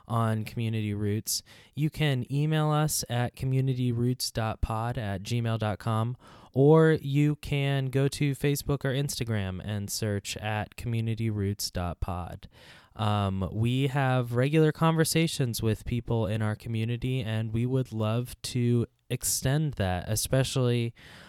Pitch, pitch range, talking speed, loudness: 120 Hz, 110-135 Hz, 115 wpm, -28 LUFS